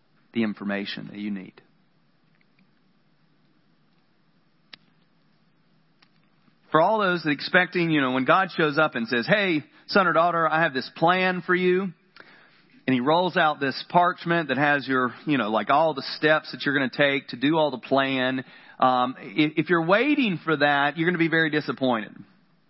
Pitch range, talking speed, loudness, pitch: 130-175 Hz, 175 wpm, -23 LUFS, 155 Hz